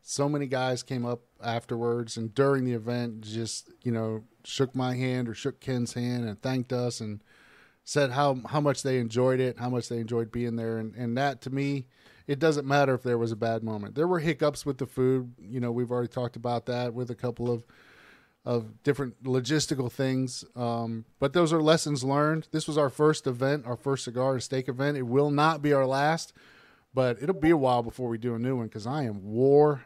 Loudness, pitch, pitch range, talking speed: -28 LUFS, 125 Hz, 120-140 Hz, 220 wpm